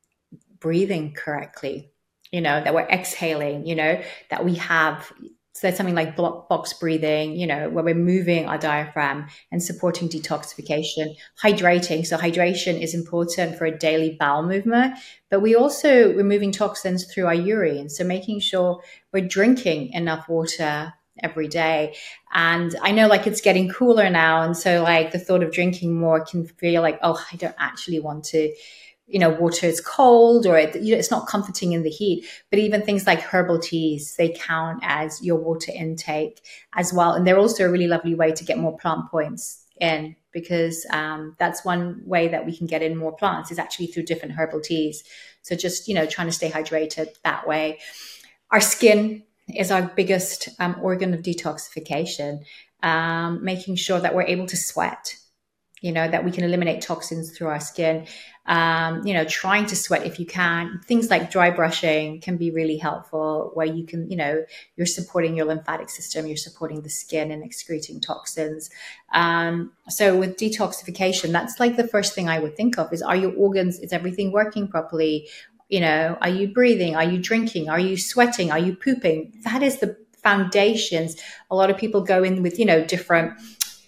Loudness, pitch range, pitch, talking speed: -22 LUFS, 160-190 Hz, 170 Hz, 185 wpm